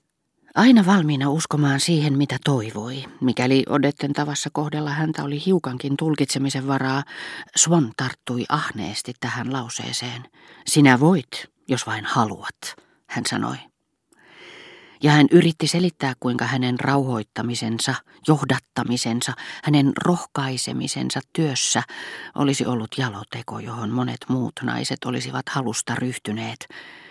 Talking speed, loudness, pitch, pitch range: 105 wpm, -22 LUFS, 135 Hz, 125-150 Hz